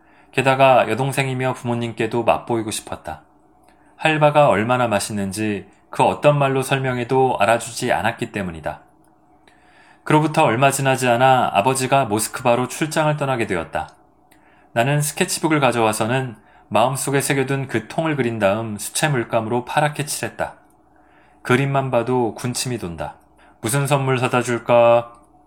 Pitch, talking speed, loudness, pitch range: 125 Hz, 320 characters per minute, -19 LUFS, 115-140 Hz